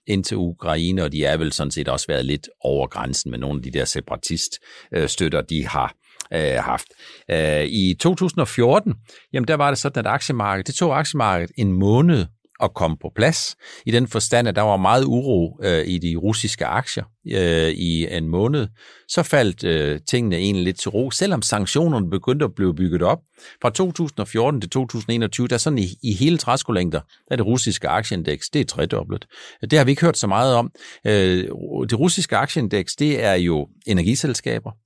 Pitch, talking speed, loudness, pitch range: 110 Hz, 190 wpm, -20 LUFS, 90-130 Hz